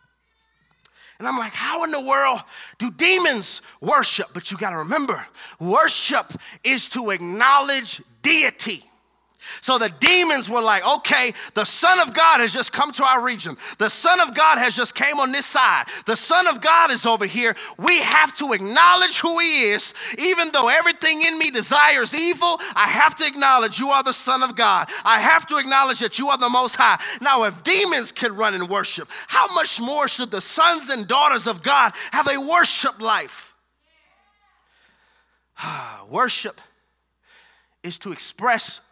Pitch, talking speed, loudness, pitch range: 275 Hz, 170 wpm, -17 LUFS, 235-325 Hz